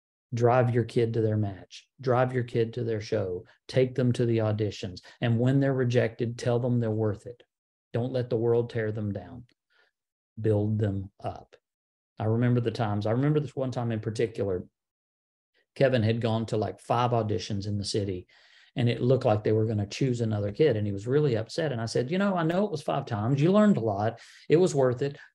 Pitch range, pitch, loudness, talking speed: 110-125 Hz, 115 Hz, -27 LUFS, 220 wpm